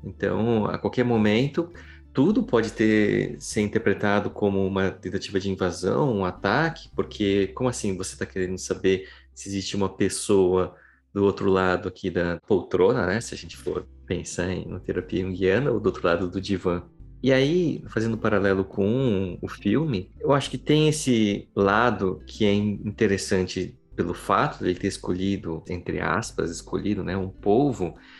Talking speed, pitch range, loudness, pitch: 170 wpm, 95-105 Hz, -25 LUFS, 95 Hz